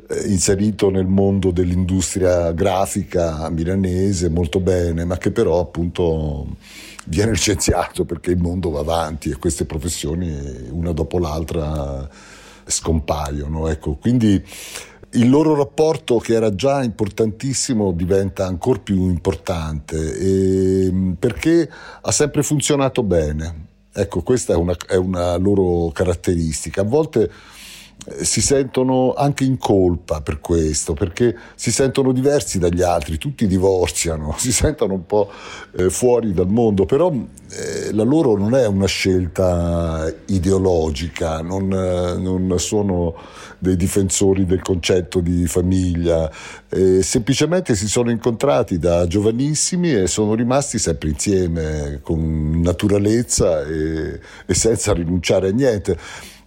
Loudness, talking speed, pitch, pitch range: -18 LUFS, 125 wpm, 95 Hz, 85-105 Hz